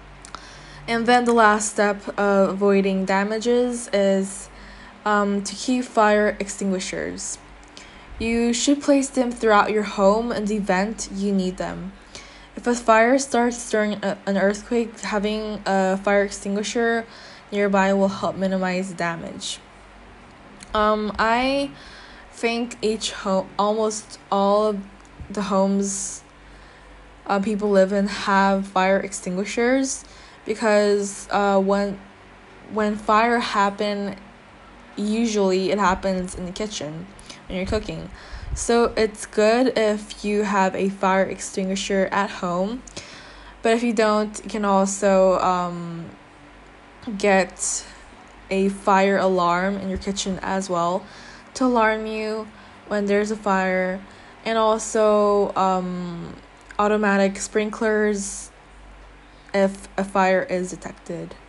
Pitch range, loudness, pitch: 195-215 Hz, -22 LUFS, 200 Hz